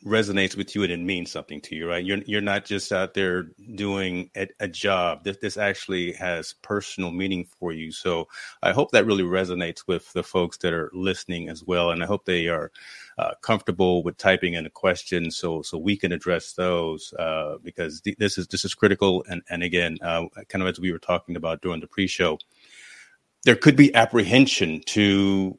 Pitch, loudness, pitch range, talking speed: 95 Hz, -24 LUFS, 85-100 Hz, 205 wpm